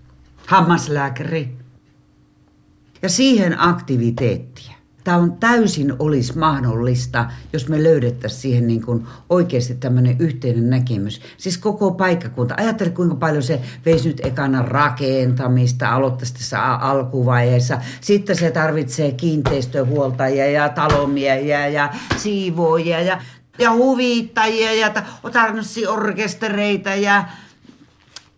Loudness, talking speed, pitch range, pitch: -18 LUFS, 100 wpm, 125-185 Hz, 145 Hz